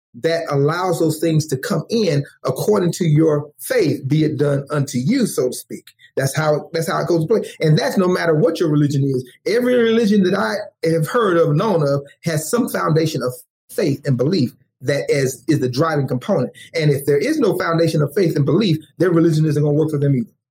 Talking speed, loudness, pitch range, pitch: 220 wpm, -18 LUFS, 145-170 Hz, 155 Hz